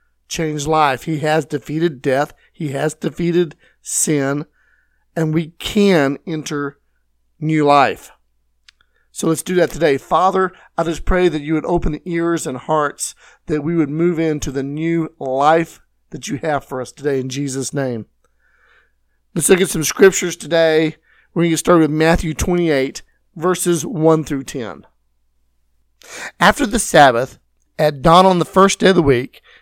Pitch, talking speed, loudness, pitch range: 155 Hz, 160 wpm, -17 LUFS, 140-170 Hz